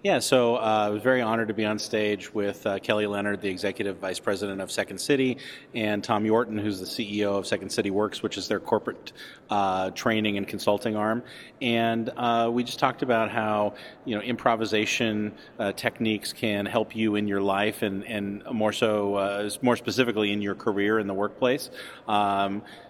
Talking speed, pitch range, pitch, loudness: 190 wpm, 100-115 Hz, 105 Hz, -26 LUFS